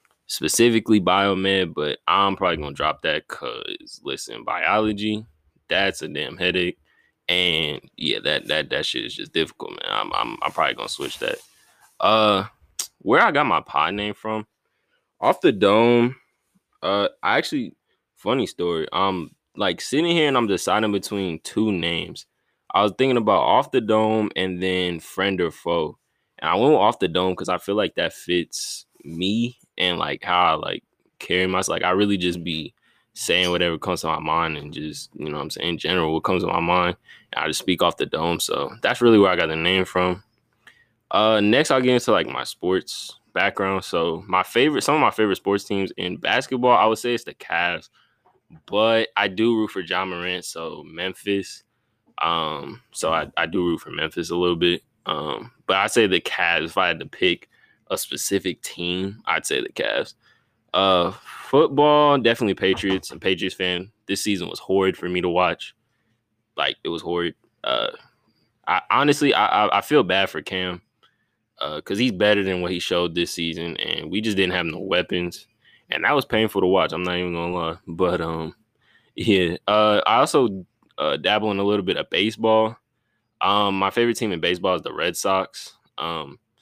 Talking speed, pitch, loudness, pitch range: 190 wpm, 95 Hz, -22 LUFS, 90-110 Hz